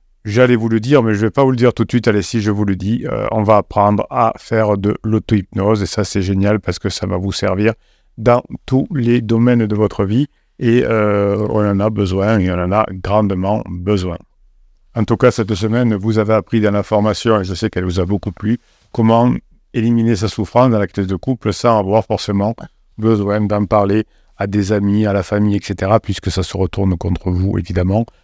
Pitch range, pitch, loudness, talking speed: 100-115 Hz, 105 Hz, -16 LUFS, 225 wpm